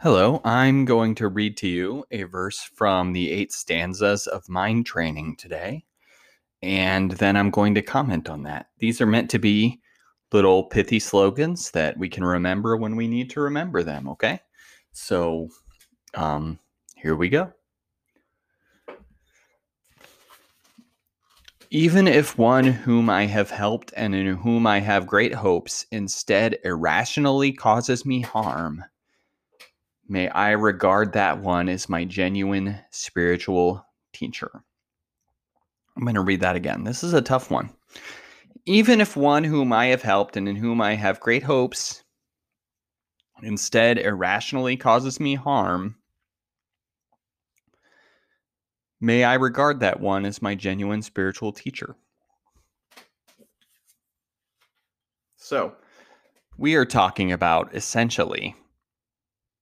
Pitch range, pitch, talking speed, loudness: 95-120 Hz, 105 Hz, 125 wpm, -22 LUFS